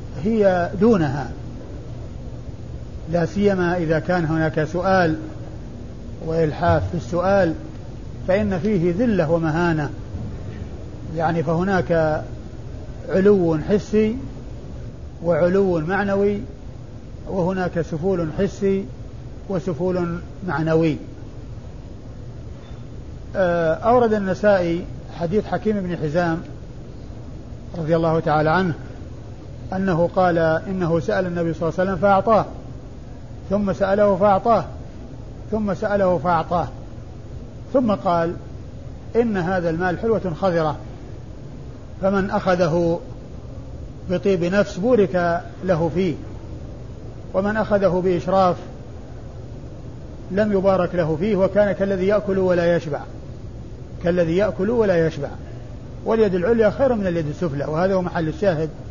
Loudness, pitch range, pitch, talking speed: -20 LUFS, 155-195 Hz, 175 Hz, 95 wpm